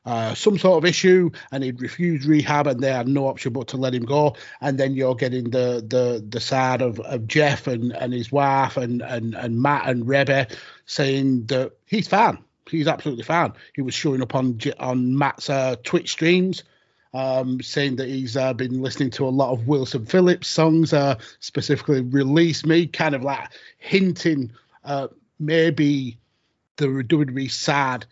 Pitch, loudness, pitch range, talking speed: 135 Hz, -21 LUFS, 125-150 Hz, 180 wpm